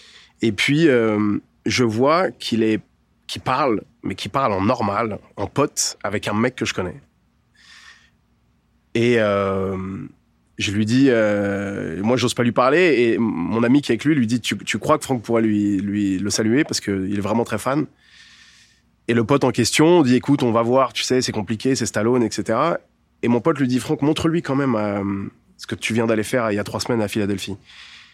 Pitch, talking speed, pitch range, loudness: 115 Hz, 210 wpm, 105-125 Hz, -20 LUFS